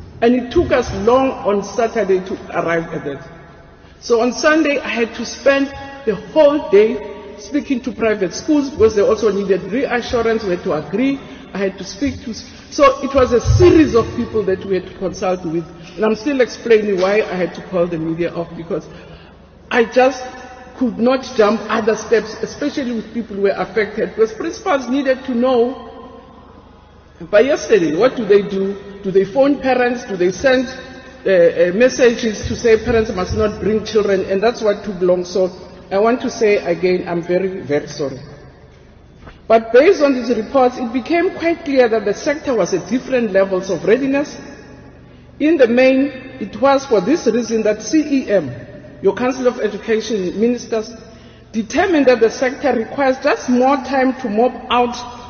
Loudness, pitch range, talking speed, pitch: -16 LUFS, 200-260 Hz, 180 wpm, 230 Hz